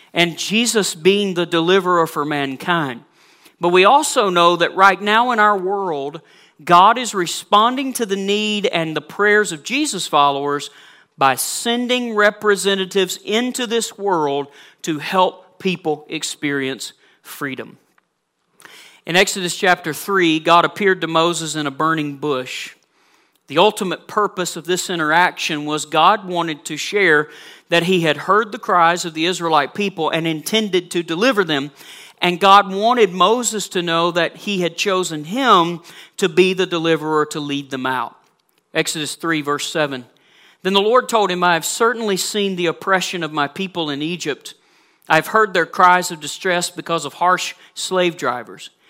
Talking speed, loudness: 160 wpm, -17 LUFS